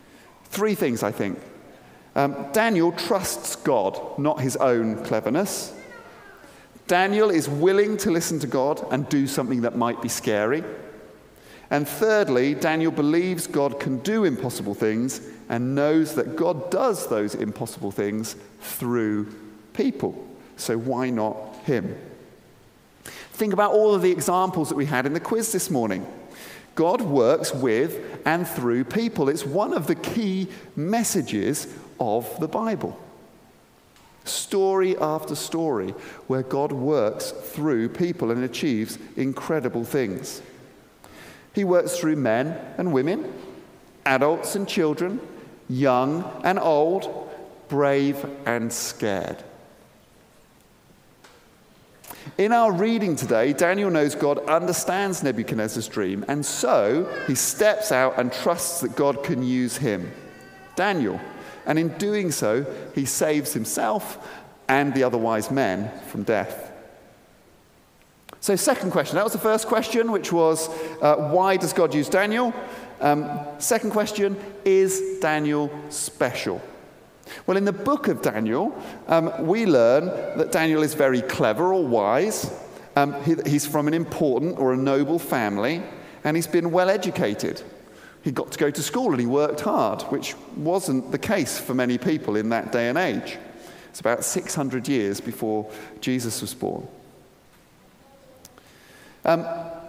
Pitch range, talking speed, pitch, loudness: 130-185 Hz, 135 wpm, 150 Hz, -23 LUFS